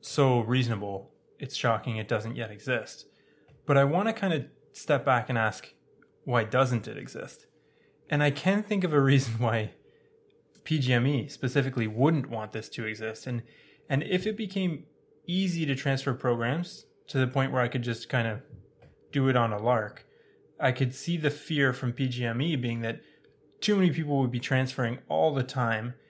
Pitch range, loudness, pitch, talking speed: 120-150 Hz, -28 LUFS, 135 Hz, 195 wpm